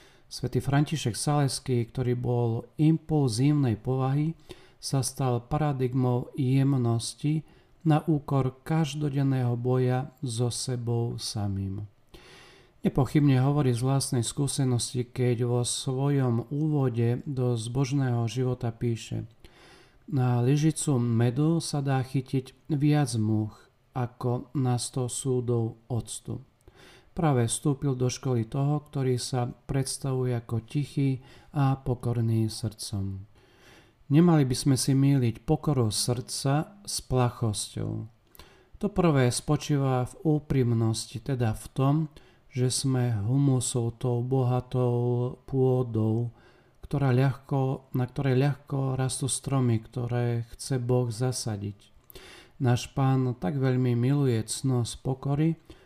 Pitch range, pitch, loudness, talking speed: 120-140 Hz, 125 Hz, -27 LUFS, 105 wpm